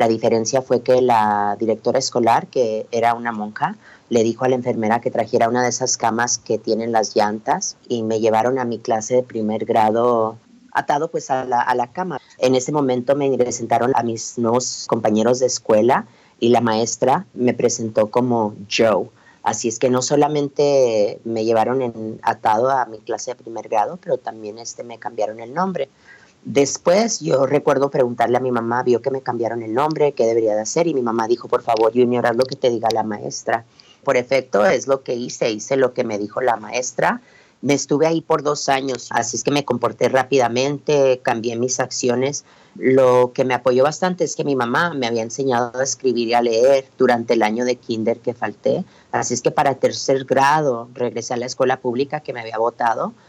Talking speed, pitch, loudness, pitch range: 205 wpm, 125 Hz, -19 LUFS, 115-135 Hz